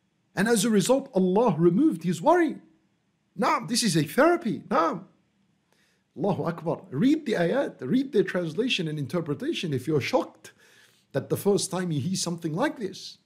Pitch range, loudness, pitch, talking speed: 165-225 Hz, -25 LUFS, 185 Hz, 170 wpm